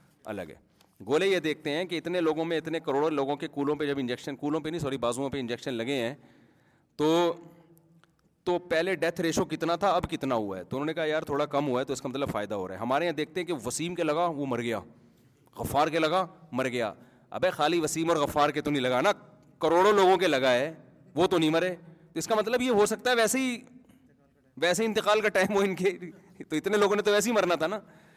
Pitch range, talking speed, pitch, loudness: 140-180 Hz, 250 wpm, 165 Hz, -28 LUFS